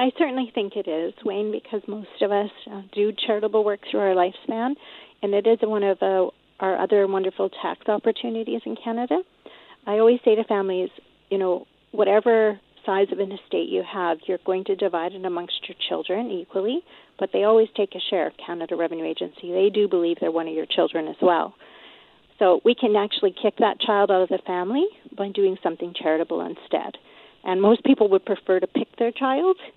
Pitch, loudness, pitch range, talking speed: 200 Hz, -23 LUFS, 185-225 Hz, 200 wpm